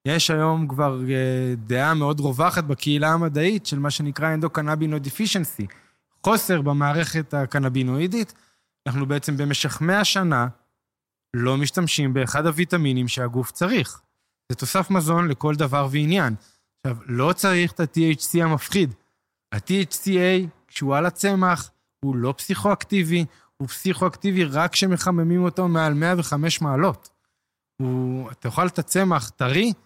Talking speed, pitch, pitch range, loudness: 125 wpm, 155 Hz, 135-180 Hz, -22 LUFS